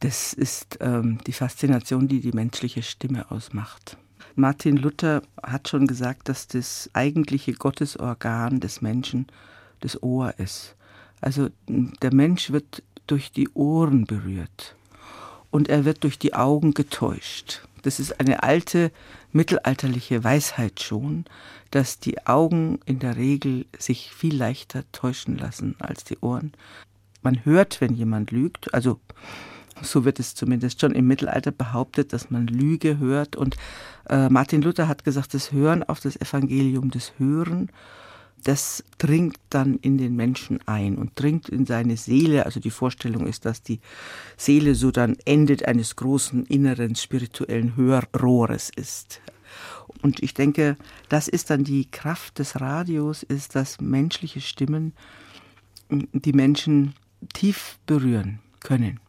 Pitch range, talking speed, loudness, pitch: 120-145 Hz, 140 wpm, -23 LUFS, 135 Hz